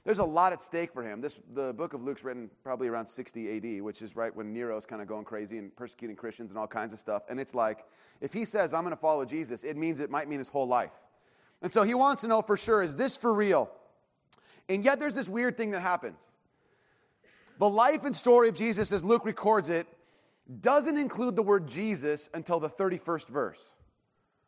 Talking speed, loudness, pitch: 225 wpm, -30 LUFS, 170 Hz